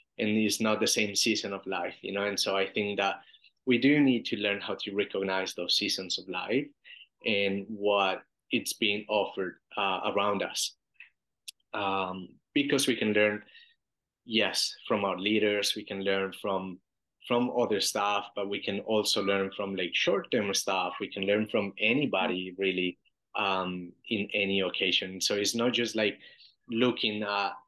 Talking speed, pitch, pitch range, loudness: 165 wpm, 100 Hz, 95-110 Hz, -29 LUFS